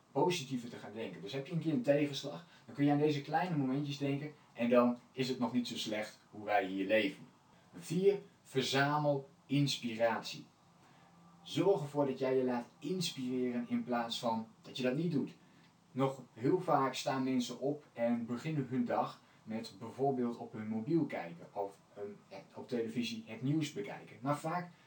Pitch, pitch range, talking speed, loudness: 135 Hz, 120-150 Hz, 180 wpm, -36 LUFS